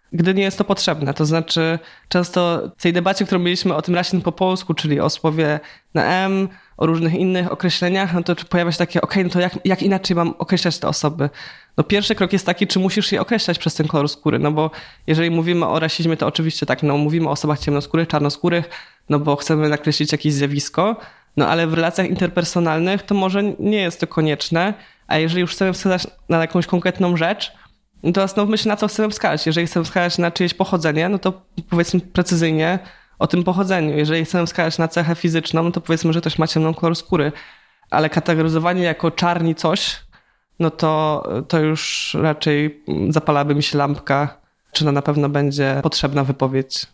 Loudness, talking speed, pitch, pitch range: -19 LUFS, 195 wpm, 170 Hz, 155-185 Hz